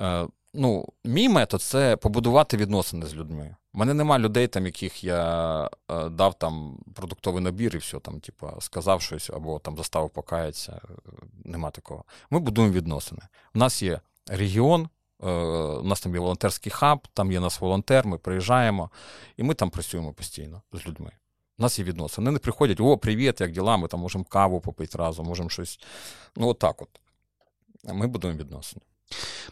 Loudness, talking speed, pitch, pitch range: -25 LUFS, 165 wpm, 95 Hz, 85-115 Hz